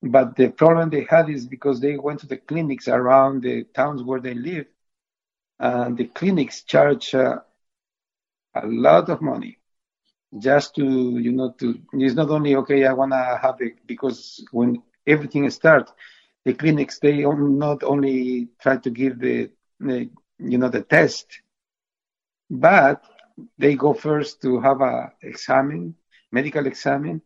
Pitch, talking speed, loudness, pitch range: 135 Hz, 150 wpm, -20 LUFS, 125-145 Hz